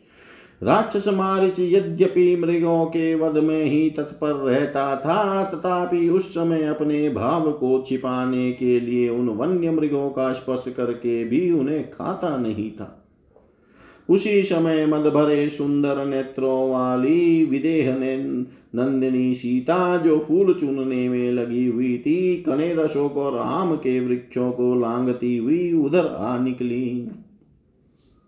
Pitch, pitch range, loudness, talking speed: 145 Hz, 125-170 Hz, -21 LUFS, 125 wpm